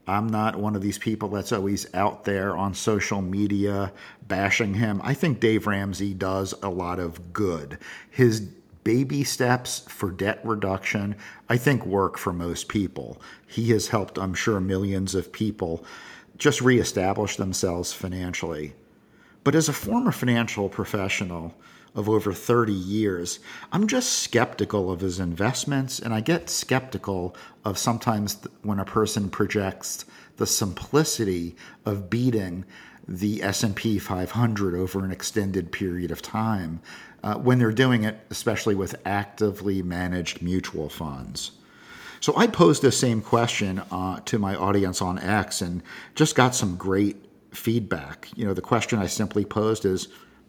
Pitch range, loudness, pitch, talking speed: 95-115 Hz, -25 LUFS, 100 Hz, 150 wpm